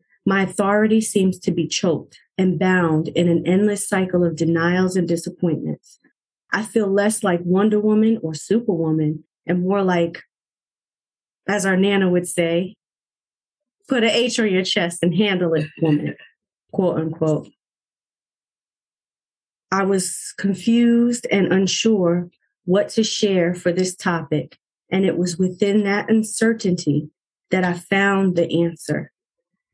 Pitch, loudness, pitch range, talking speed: 185 Hz, -19 LUFS, 170-205 Hz, 135 wpm